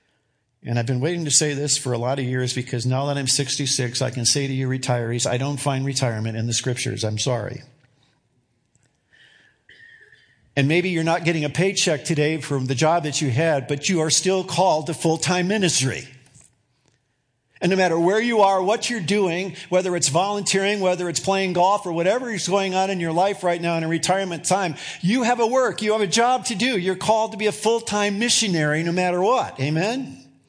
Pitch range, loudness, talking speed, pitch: 135-190 Hz, -21 LUFS, 205 wpm, 165 Hz